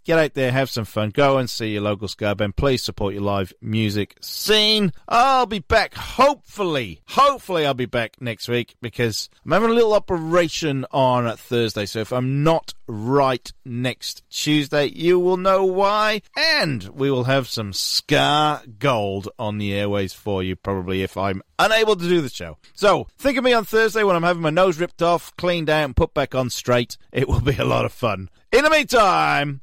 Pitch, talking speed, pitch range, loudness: 135 Hz, 200 wpm, 110-175 Hz, -20 LUFS